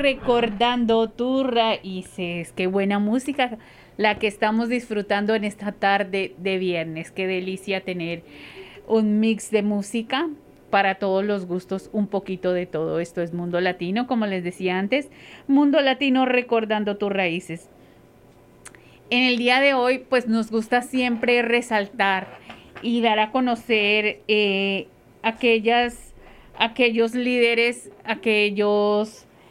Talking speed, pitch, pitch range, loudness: 125 wpm, 215 Hz, 195-240 Hz, -22 LUFS